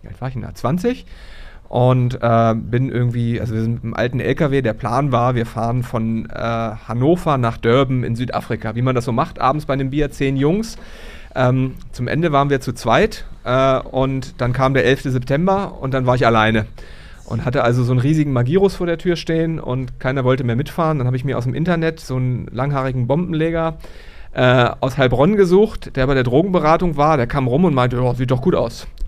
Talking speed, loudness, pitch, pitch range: 215 wpm, -18 LUFS, 130 Hz, 120-150 Hz